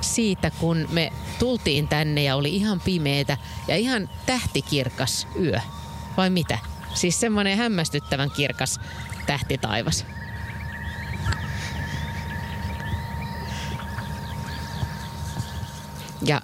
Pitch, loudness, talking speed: 135 Hz, -26 LUFS, 80 wpm